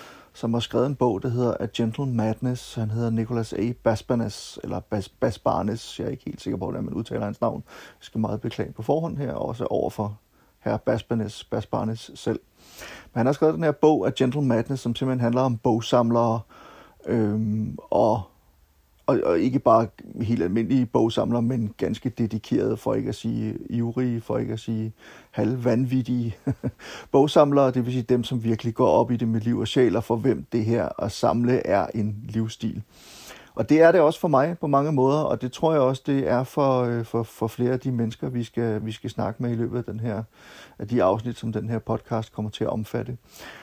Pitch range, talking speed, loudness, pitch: 110-125 Hz, 205 wpm, -24 LUFS, 115 Hz